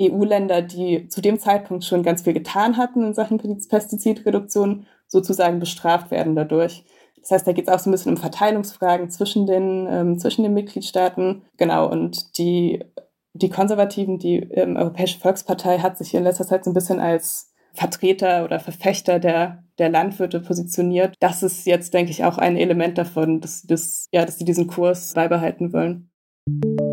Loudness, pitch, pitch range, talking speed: -20 LUFS, 180 Hz, 170-195 Hz, 175 wpm